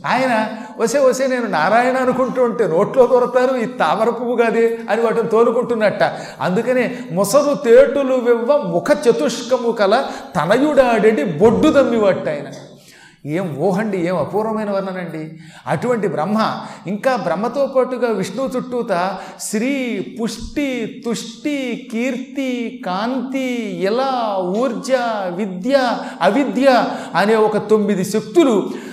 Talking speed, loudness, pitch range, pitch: 105 wpm, -17 LUFS, 200-255 Hz, 230 Hz